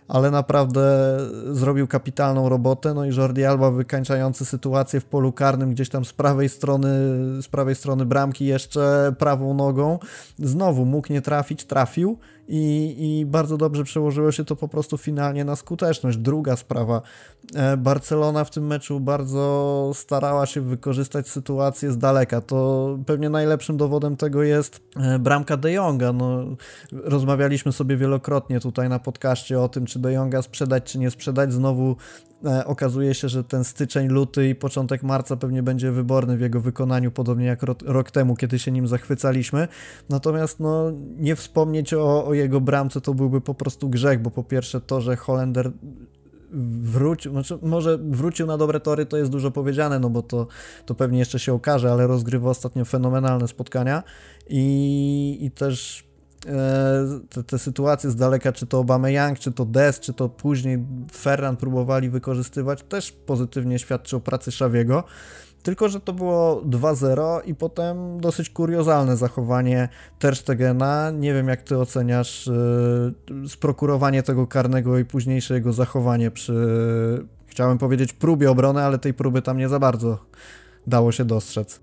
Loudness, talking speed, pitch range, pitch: -22 LUFS, 155 wpm, 130-145 Hz, 135 Hz